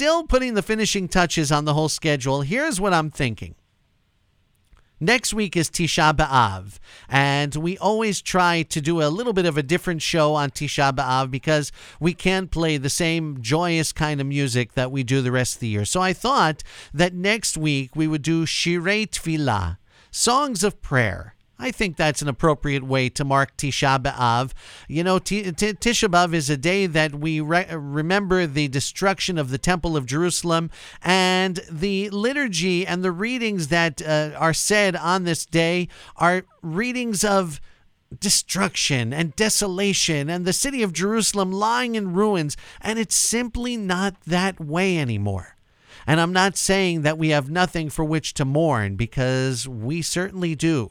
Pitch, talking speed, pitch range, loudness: 165 Hz, 170 wpm, 145-190 Hz, -21 LUFS